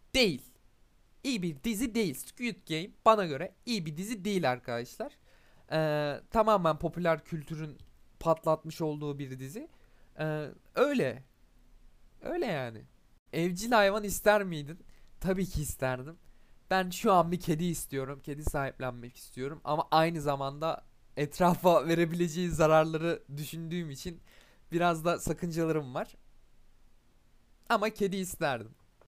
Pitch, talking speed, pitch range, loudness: 165 Hz, 120 wpm, 145-185 Hz, -31 LUFS